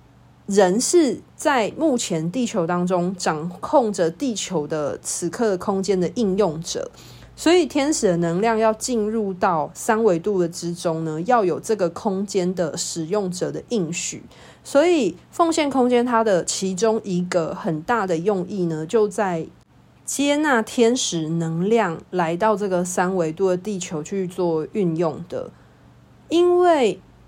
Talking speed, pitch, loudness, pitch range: 215 characters per minute, 195 Hz, -21 LUFS, 175-230 Hz